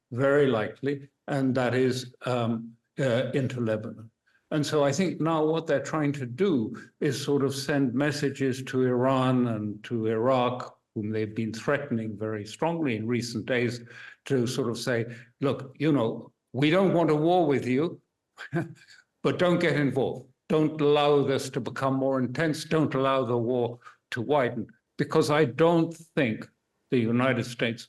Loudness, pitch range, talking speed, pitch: -27 LUFS, 120-150 Hz, 165 wpm, 135 Hz